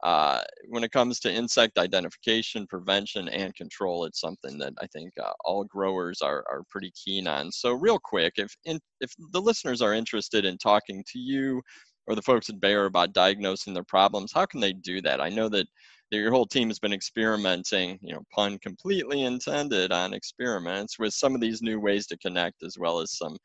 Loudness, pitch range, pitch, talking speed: -27 LUFS, 95-125 Hz, 105 Hz, 205 wpm